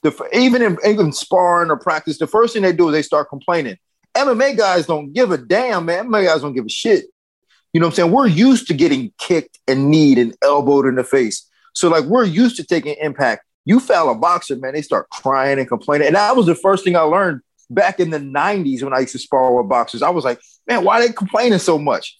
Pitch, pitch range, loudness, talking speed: 170 Hz, 140-215 Hz, -16 LUFS, 250 wpm